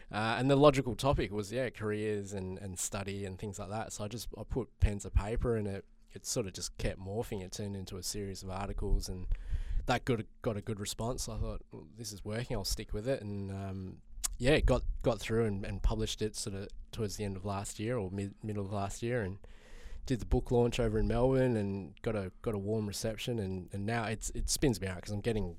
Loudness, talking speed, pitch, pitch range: -35 LUFS, 250 wpm, 105 Hz, 95-115 Hz